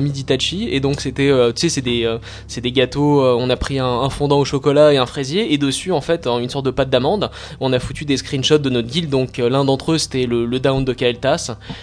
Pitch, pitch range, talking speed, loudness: 135 Hz, 125-145 Hz, 265 wpm, -17 LUFS